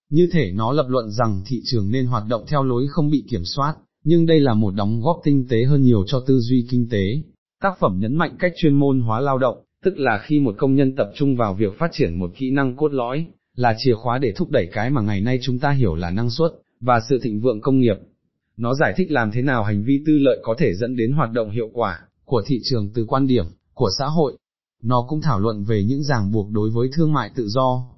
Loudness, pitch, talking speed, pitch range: -20 LUFS, 125 Hz, 260 wpm, 115-145 Hz